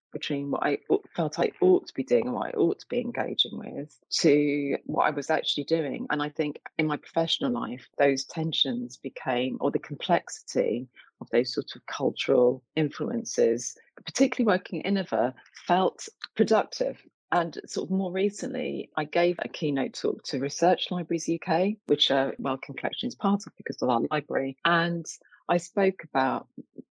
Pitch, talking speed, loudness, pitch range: 165 Hz, 170 wpm, -27 LUFS, 140-200 Hz